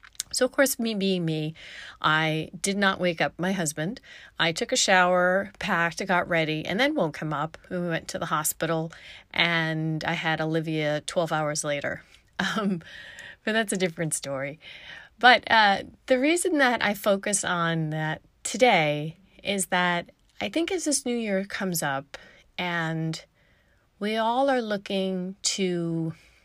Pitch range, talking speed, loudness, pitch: 160-210 Hz, 155 wpm, -25 LUFS, 180 Hz